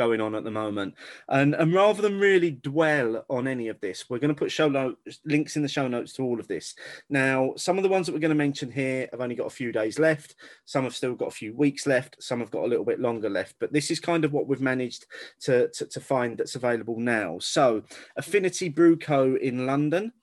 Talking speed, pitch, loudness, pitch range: 250 wpm, 140 Hz, -26 LUFS, 125-165 Hz